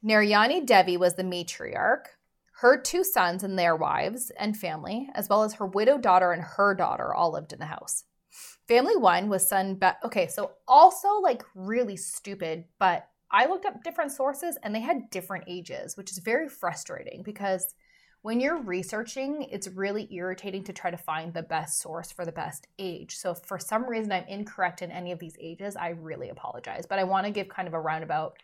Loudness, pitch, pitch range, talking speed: -27 LUFS, 195 Hz, 180-220 Hz, 200 wpm